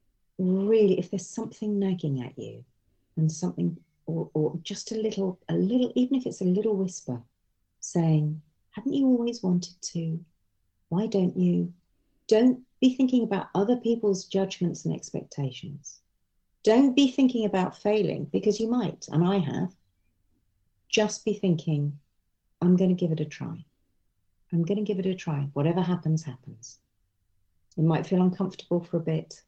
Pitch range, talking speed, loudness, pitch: 130-200 Hz, 160 wpm, -27 LUFS, 175 Hz